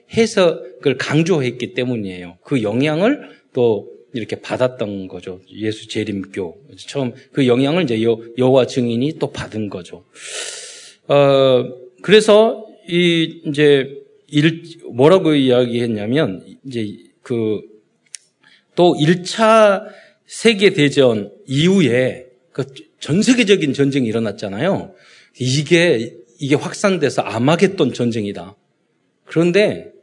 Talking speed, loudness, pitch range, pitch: 225 characters per minute, -16 LUFS, 120-190 Hz, 140 Hz